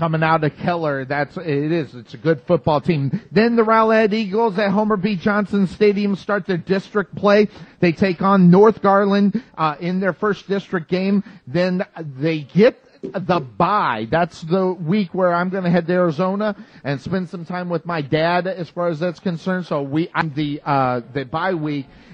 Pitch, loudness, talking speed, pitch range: 180 Hz, -19 LUFS, 190 wpm, 160-200 Hz